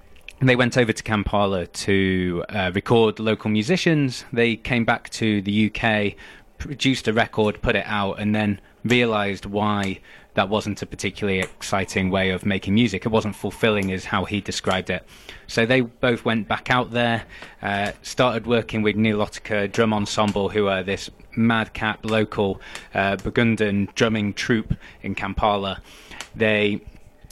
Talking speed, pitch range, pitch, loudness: 155 wpm, 100-115 Hz, 105 Hz, -22 LUFS